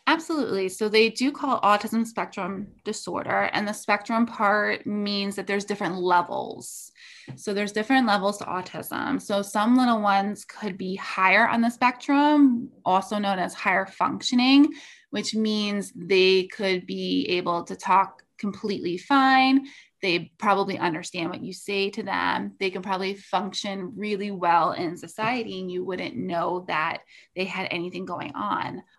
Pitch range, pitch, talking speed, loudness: 185-225 Hz, 200 Hz, 155 wpm, -24 LUFS